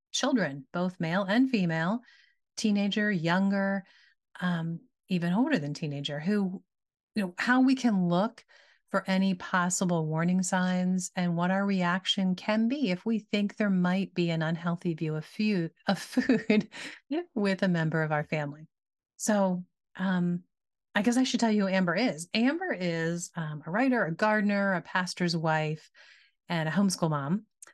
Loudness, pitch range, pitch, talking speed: -29 LUFS, 170-210 Hz, 185 Hz, 155 wpm